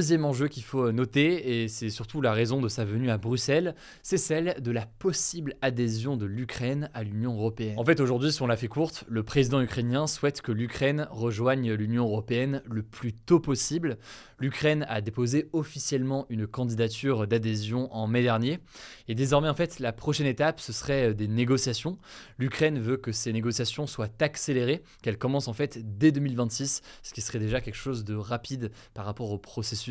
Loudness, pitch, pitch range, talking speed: -28 LUFS, 125 Hz, 115-145 Hz, 185 wpm